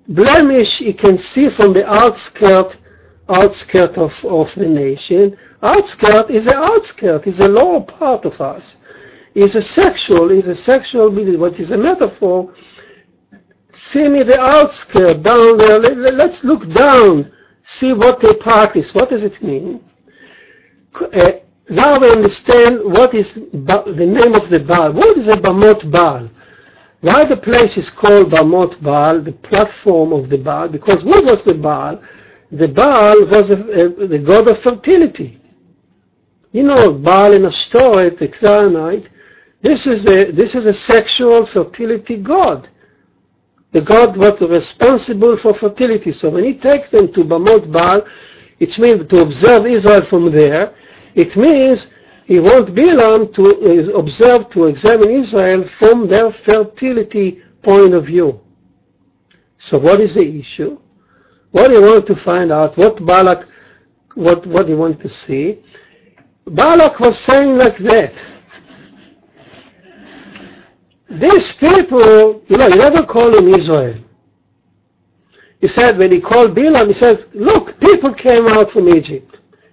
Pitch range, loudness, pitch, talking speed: 180-245 Hz, -10 LUFS, 210 Hz, 145 wpm